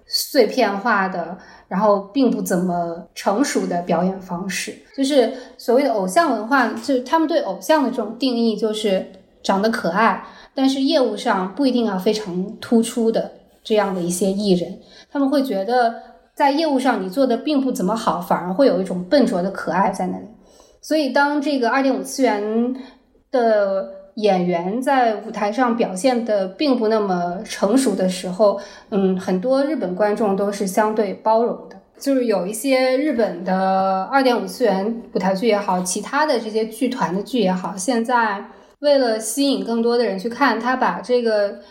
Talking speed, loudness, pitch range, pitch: 265 characters per minute, -19 LUFS, 195-255 Hz, 225 Hz